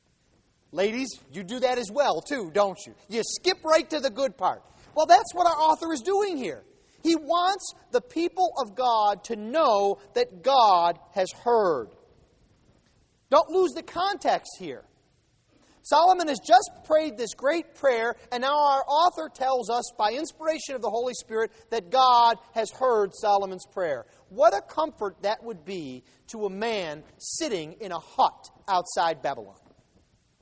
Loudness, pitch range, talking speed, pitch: -25 LUFS, 220-330 Hz, 160 wpm, 265 Hz